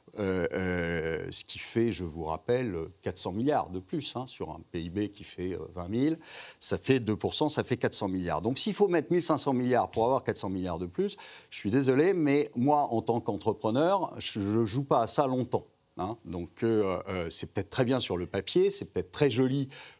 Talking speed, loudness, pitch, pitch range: 215 wpm, -30 LUFS, 115 Hz, 95-135 Hz